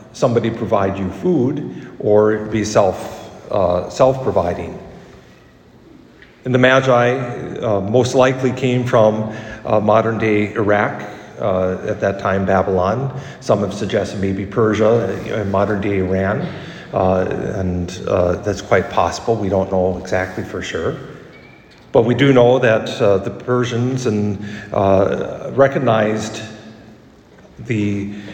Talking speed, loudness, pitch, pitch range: 125 wpm, -17 LUFS, 105 Hz, 95-120 Hz